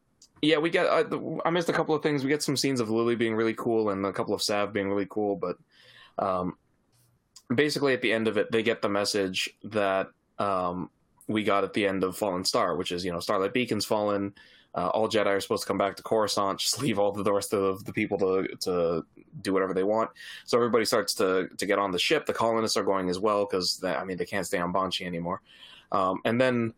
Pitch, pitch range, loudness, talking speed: 105 Hz, 95-115 Hz, -27 LUFS, 240 wpm